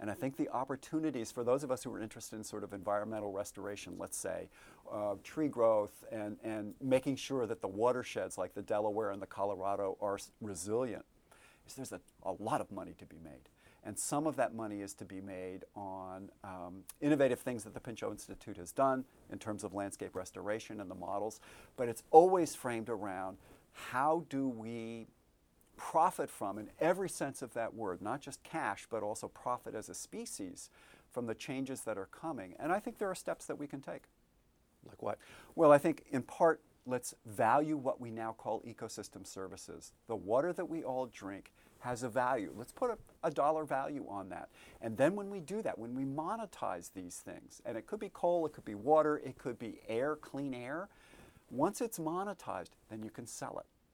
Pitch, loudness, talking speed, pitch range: 120 Hz, -37 LUFS, 200 wpm, 105-145 Hz